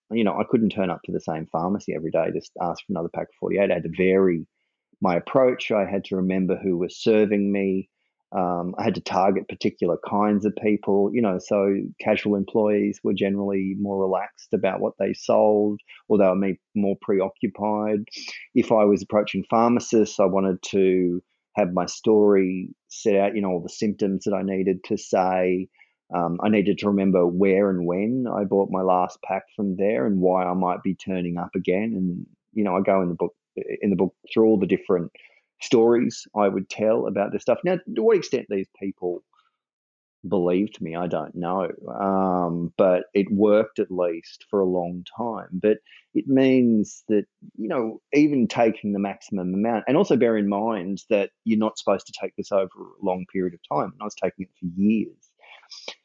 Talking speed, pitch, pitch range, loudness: 200 wpm, 100 Hz, 90-105 Hz, -23 LUFS